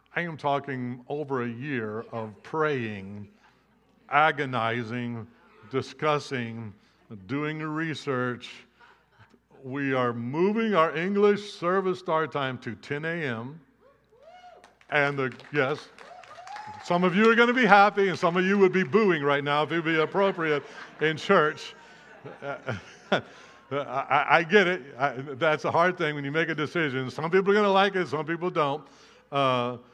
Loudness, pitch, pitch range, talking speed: -26 LUFS, 150 Hz, 130-180 Hz, 155 wpm